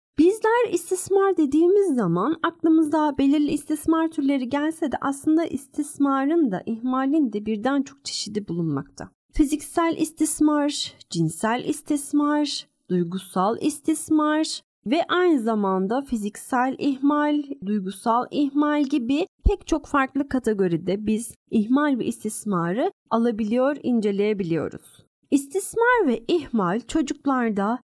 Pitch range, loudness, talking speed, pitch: 225-310 Hz, -23 LUFS, 100 wpm, 285 Hz